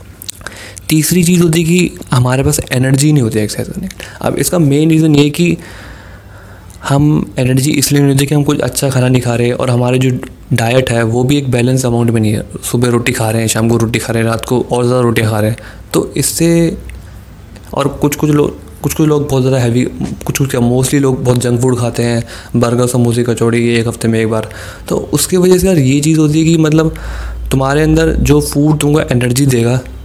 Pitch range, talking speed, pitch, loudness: 115-145 Hz, 220 wpm, 125 Hz, -12 LUFS